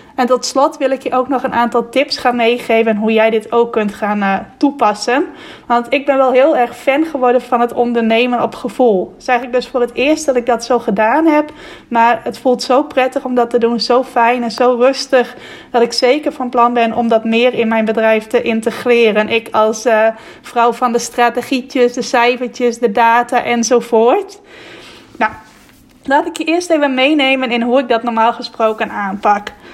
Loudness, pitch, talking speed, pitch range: -14 LUFS, 245 Hz, 205 wpm, 230-260 Hz